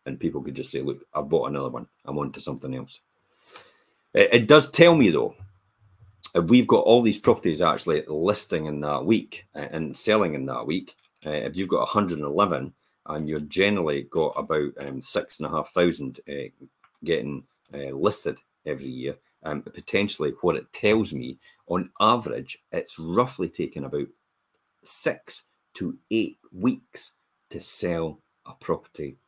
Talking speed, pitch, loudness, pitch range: 150 wpm, 85 Hz, -24 LUFS, 70-105 Hz